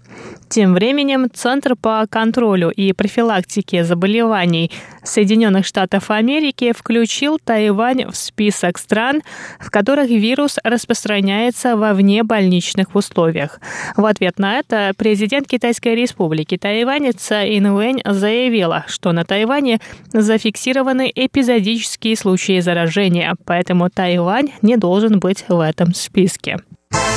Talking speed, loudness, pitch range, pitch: 110 wpm, -16 LUFS, 190-240 Hz, 215 Hz